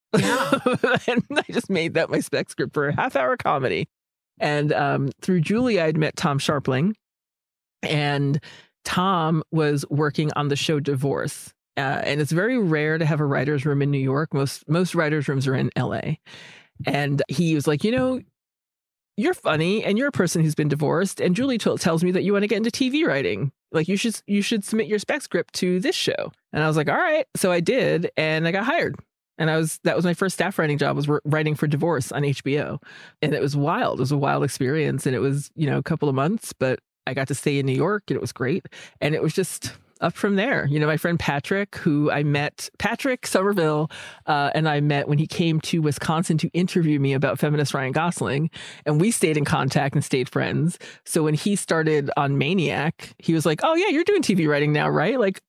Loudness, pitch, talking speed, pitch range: -23 LUFS, 155 Hz, 225 wpm, 145-190 Hz